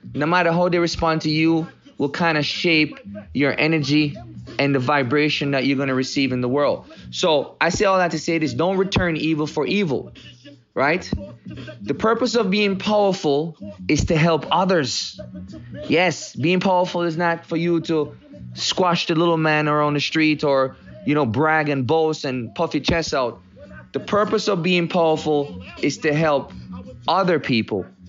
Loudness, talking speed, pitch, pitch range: -20 LUFS, 175 wpm, 155 Hz, 140-170 Hz